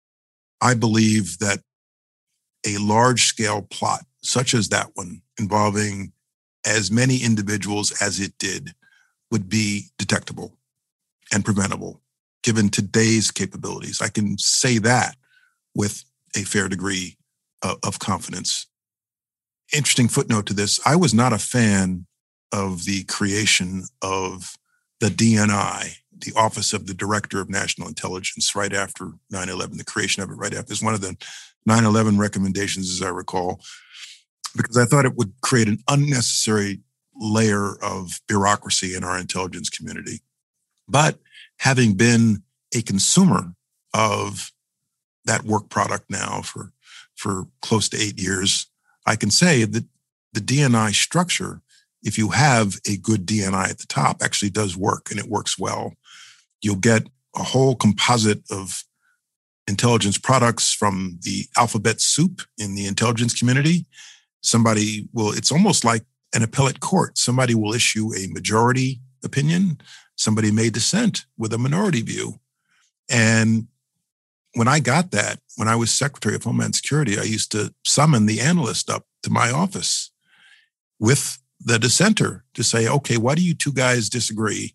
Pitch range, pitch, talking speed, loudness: 100-125 Hz, 110 Hz, 145 wpm, -20 LUFS